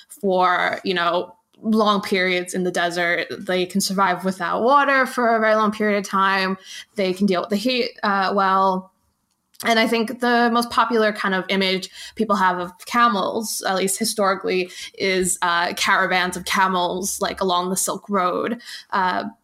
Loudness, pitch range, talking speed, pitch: -20 LUFS, 185-220 Hz, 170 wpm, 195 Hz